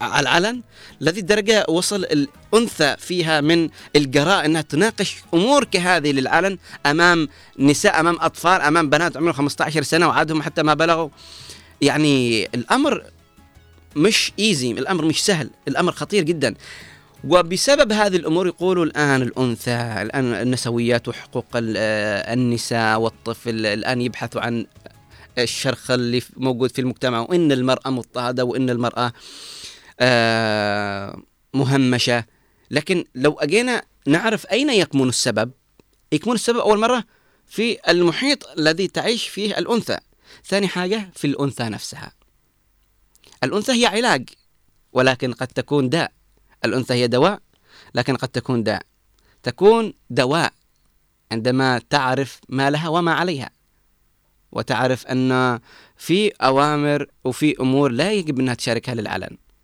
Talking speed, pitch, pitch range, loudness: 120 wpm, 140 Hz, 120-175 Hz, -19 LUFS